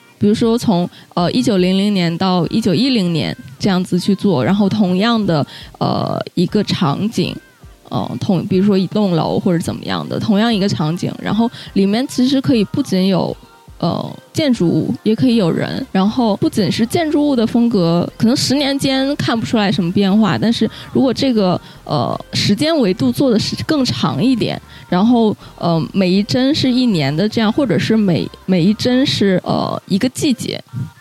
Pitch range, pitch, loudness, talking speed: 180-235 Hz, 205 Hz, -16 LUFS, 270 characters per minute